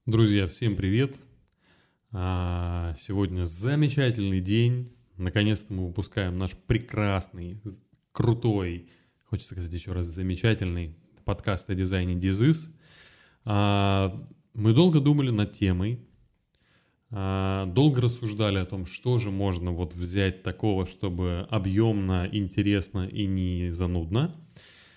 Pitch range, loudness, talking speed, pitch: 90-115 Hz, -27 LUFS, 100 wpm, 100 Hz